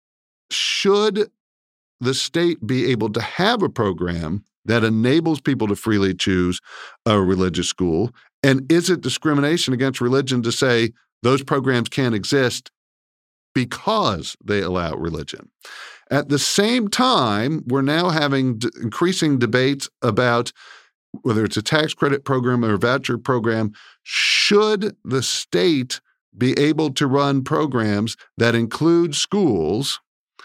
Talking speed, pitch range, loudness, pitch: 130 wpm, 110-150 Hz, -20 LUFS, 130 Hz